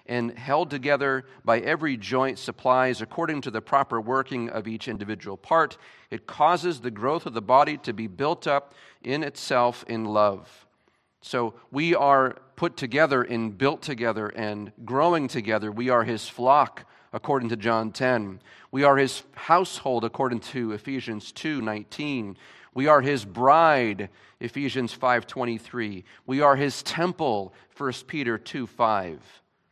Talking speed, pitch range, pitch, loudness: 150 wpm, 115-140 Hz, 125 Hz, -25 LUFS